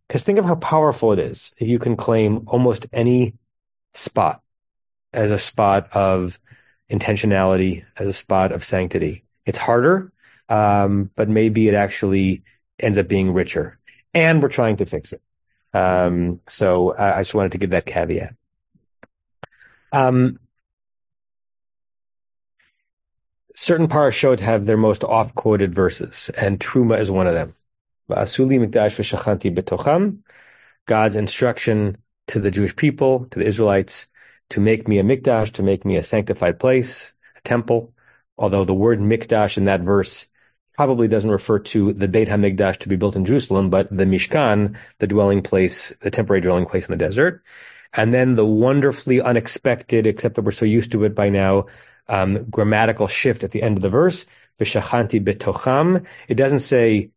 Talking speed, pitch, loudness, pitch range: 155 wpm, 105 Hz, -19 LUFS, 100-120 Hz